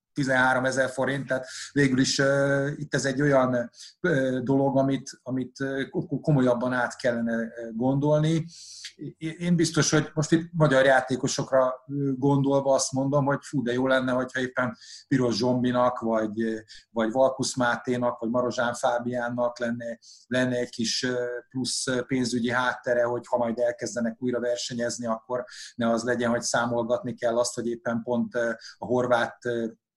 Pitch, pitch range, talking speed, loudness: 125 Hz, 120-135 Hz, 155 wpm, -26 LUFS